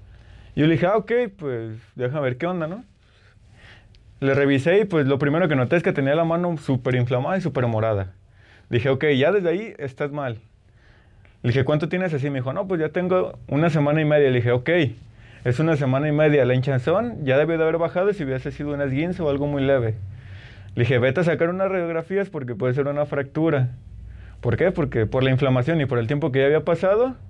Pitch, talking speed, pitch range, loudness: 140 Hz, 225 wpm, 120-160 Hz, -22 LUFS